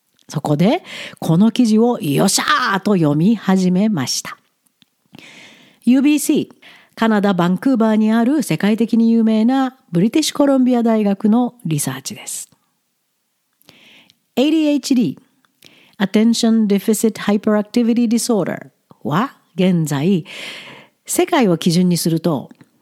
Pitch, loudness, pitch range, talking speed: 220 Hz, -16 LUFS, 190-245 Hz, 310 characters per minute